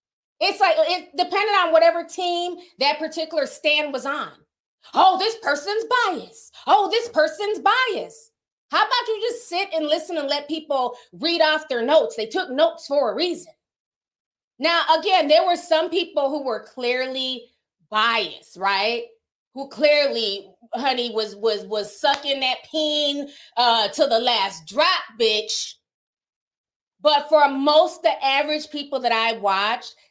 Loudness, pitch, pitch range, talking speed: -21 LUFS, 300 Hz, 250-345 Hz, 150 wpm